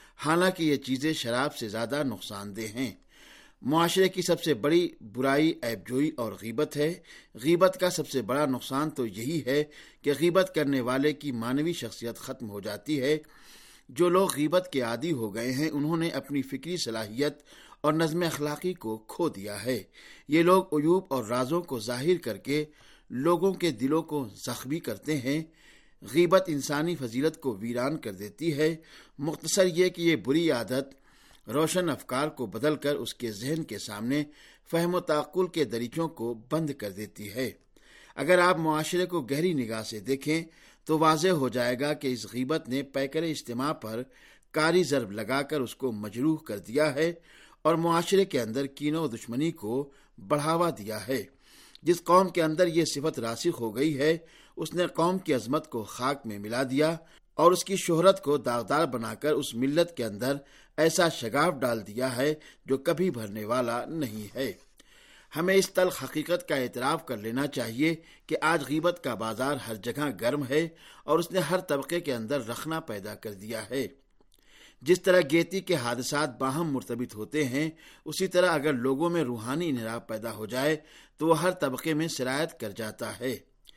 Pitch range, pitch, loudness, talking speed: 125-165 Hz, 150 Hz, -28 LUFS, 180 wpm